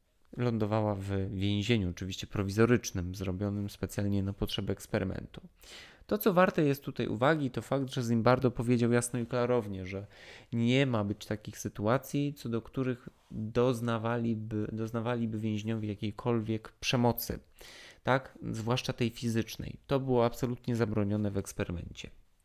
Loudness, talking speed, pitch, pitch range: -32 LUFS, 130 wpm, 115 Hz, 105-125 Hz